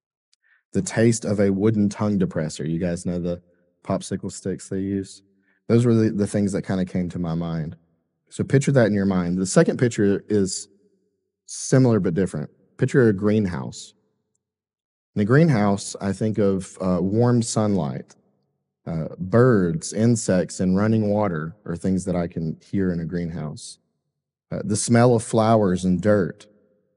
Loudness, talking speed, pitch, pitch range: -22 LUFS, 165 wpm, 100 Hz, 90-110 Hz